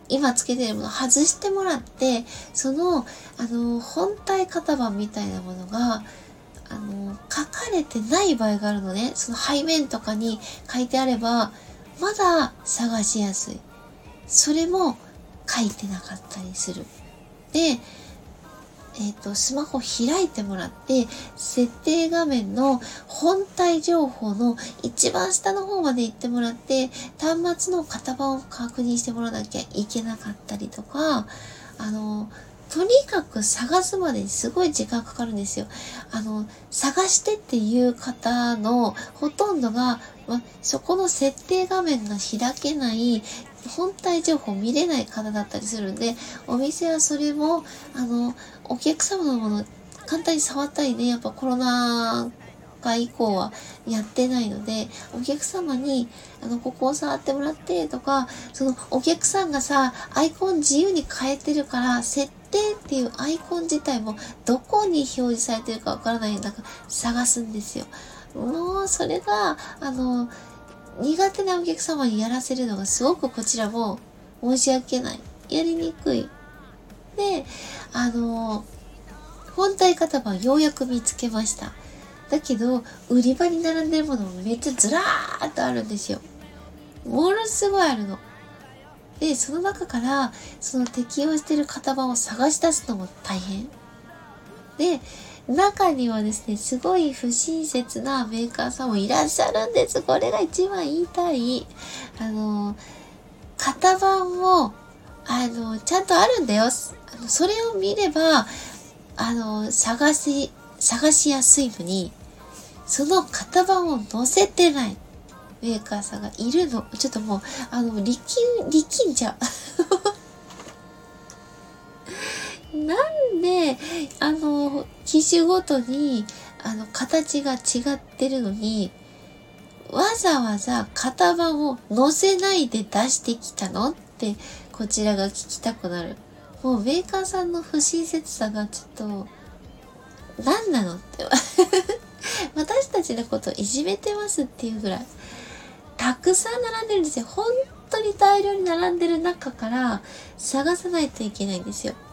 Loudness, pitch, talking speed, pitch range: -23 LUFS, 265 Hz, 270 characters per minute, 230-330 Hz